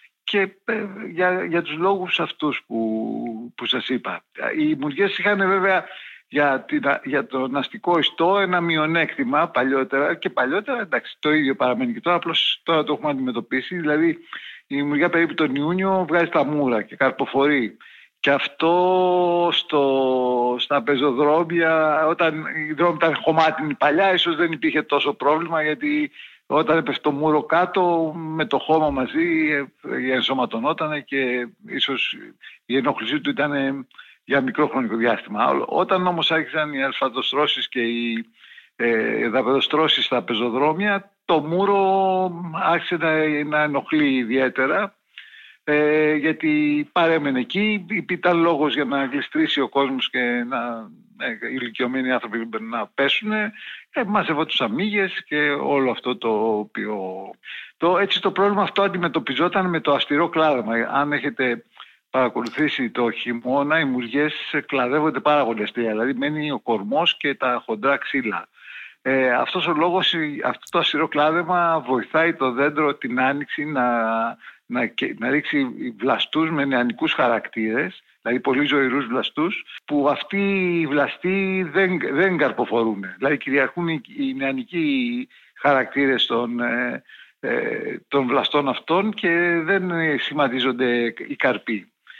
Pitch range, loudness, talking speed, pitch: 135-175 Hz, -21 LUFS, 135 wpm, 150 Hz